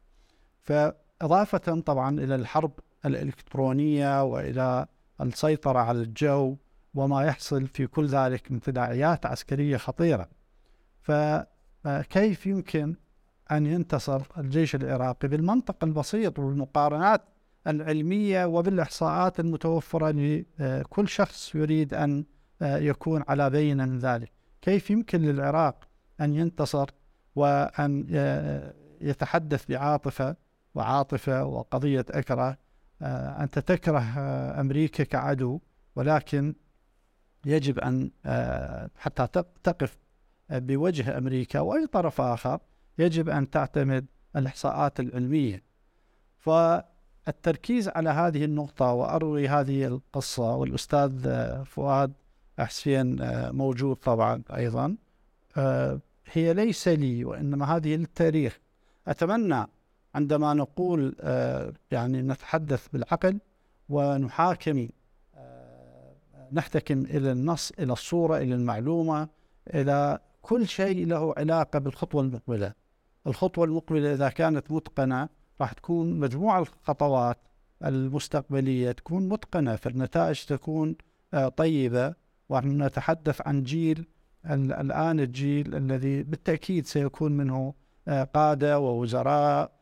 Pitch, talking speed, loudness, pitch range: 145 Hz, 95 wpm, -27 LUFS, 130-160 Hz